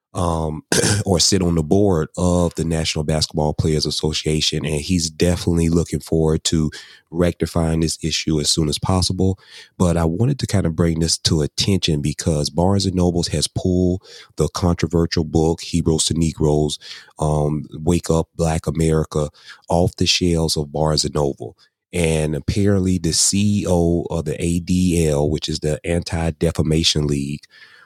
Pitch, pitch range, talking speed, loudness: 80 Hz, 75-90 Hz, 155 wpm, -19 LUFS